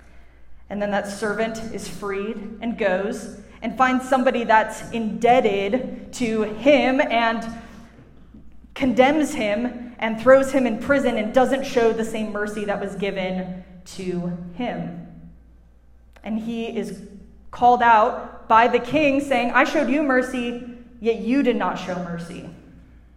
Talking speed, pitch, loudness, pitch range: 135 wpm, 225 Hz, -21 LUFS, 200-245 Hz